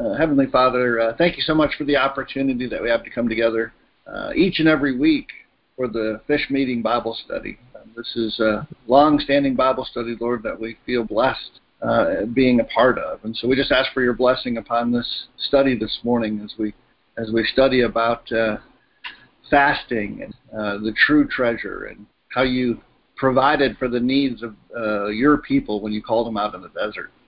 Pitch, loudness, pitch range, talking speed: 125 Hz, -20 LUFS, 115-135 Hz, 200 wpm